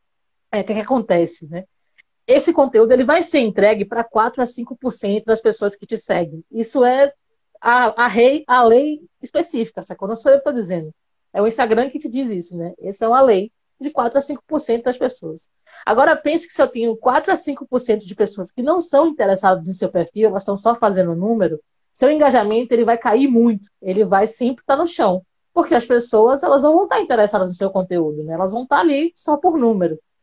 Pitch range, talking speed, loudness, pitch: 200-275 Hz, 225 wpm, -17 LUFS, 230 Hz